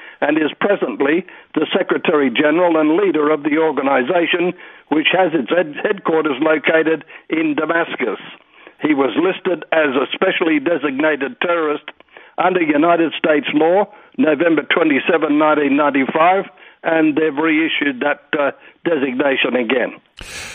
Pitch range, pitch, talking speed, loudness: 155-180 Hz, 160 Hz, 120 wpm, -16 LUFS